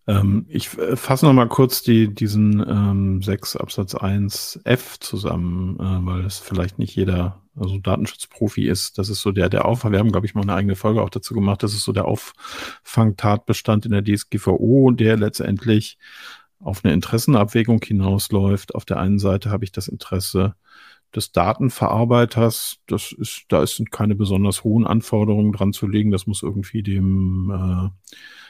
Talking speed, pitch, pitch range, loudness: 165 wpm, 105 Hz, 95-110 Hz, -20 LUFS